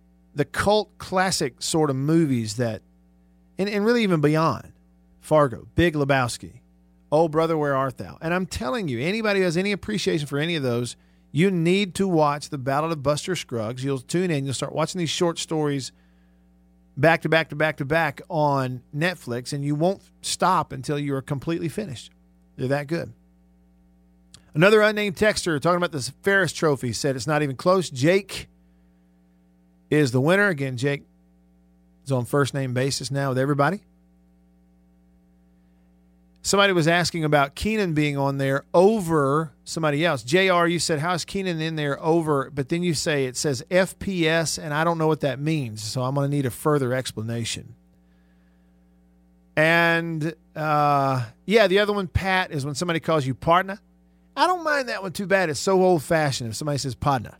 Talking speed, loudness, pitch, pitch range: 175 wpm, -23 LUFS, 145 Hz, 110-170 Hz